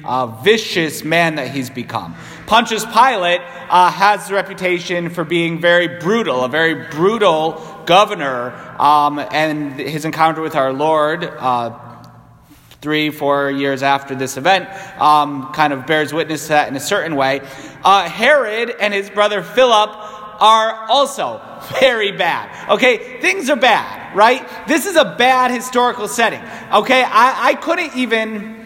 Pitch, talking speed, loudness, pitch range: 175 Hz, 150 wpm, -15 LUFS, 150-215 Hz